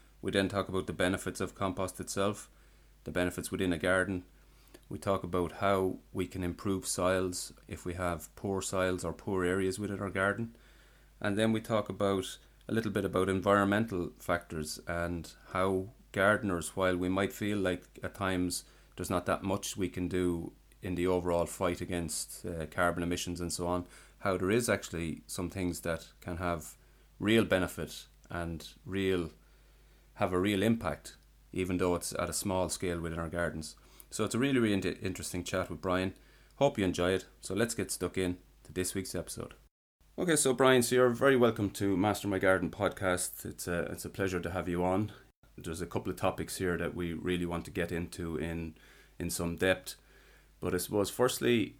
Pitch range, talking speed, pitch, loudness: 85-100 Hz, 190 wpm, 90 Hz, -33 LUFS